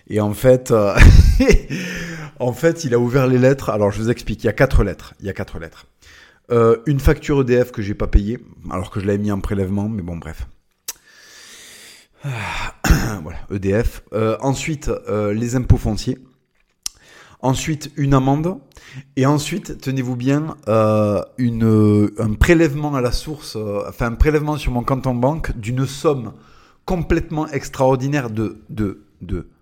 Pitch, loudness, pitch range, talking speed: 120 Hz, -19 LUFS, 105-140 Hz, 170 wpm